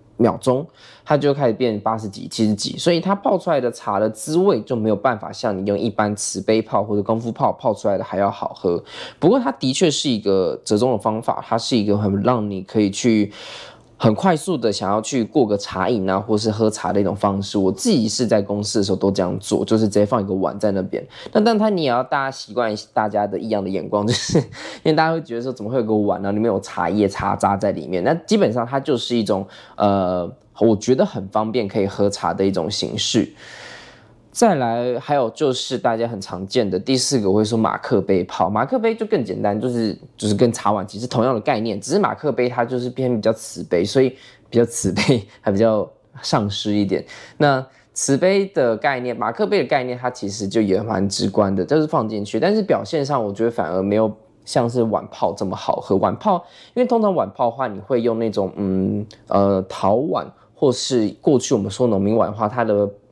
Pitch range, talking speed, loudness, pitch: 100-130 Hz, 320 characters per minute, -20 LUFS, 110 Hz